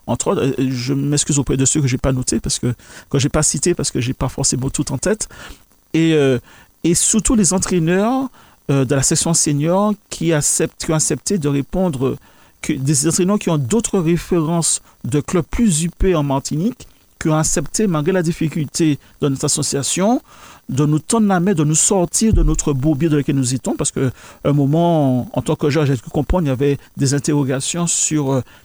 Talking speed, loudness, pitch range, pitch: 210 wpm, -17 LUFS, 140-175 Hz, 155 Hz